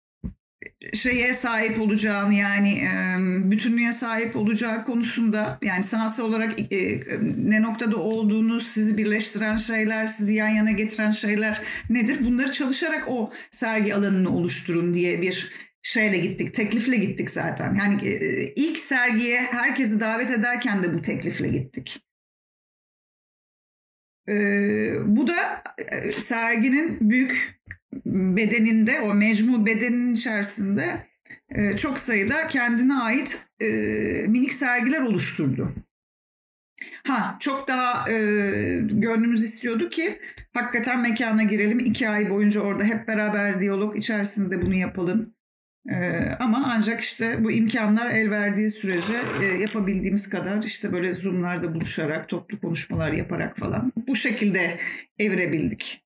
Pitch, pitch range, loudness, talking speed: 220 Hz, 205-240 Hz, -23 LUFS, 115 wpm